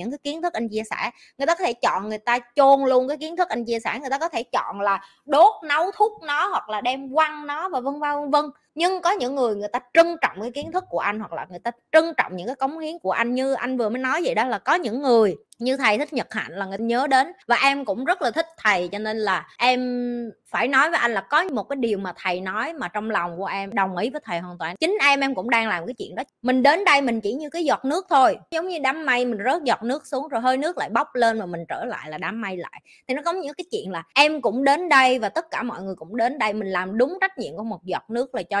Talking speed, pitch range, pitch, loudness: 300 wpm, 215-290 Hz, 250 Hz, -22 LUFS